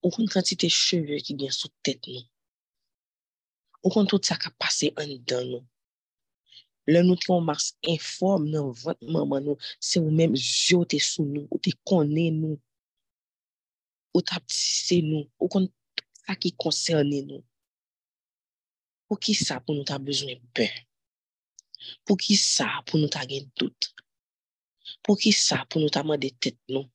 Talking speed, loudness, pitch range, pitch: 170 wpm, -25 LUFS, 130-175 Hz, 150 Hz